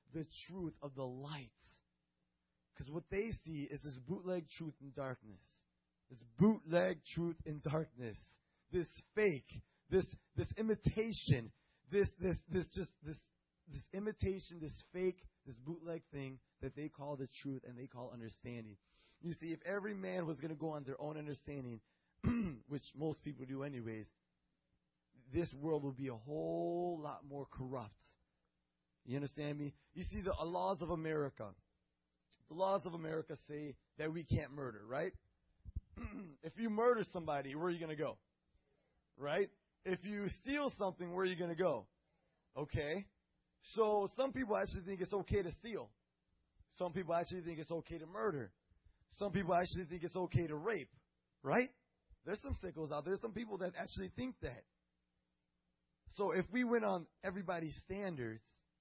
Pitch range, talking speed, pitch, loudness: 130-185 Hz, 160 wpm, 155 Hz, -42 LUFS